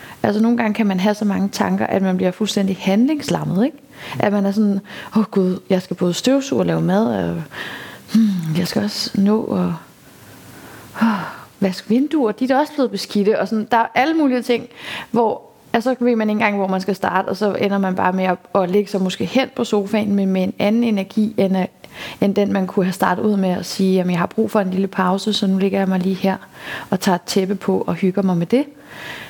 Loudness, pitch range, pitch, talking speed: -19 LUFS, 190-220 Hz, 200 Hz, 235 wpm